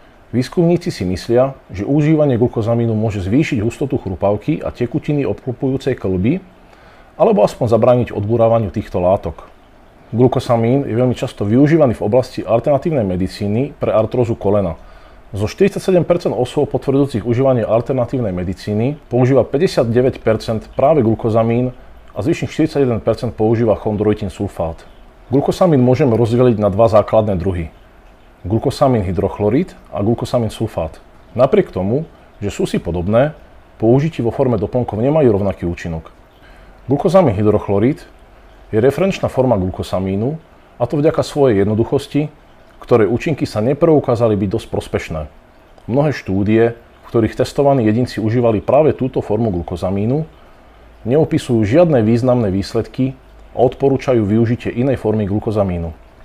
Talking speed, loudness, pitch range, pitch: 120 wpm, -16 LUFS, 105-135 Hz, 115 Hz